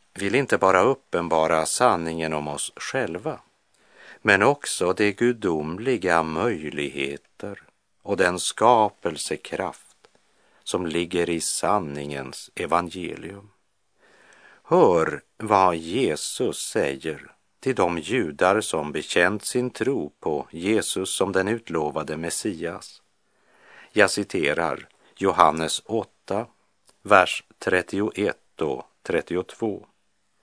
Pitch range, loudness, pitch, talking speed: 80-100 Hz, -24 LUFS, 85 Hz, 90 wpm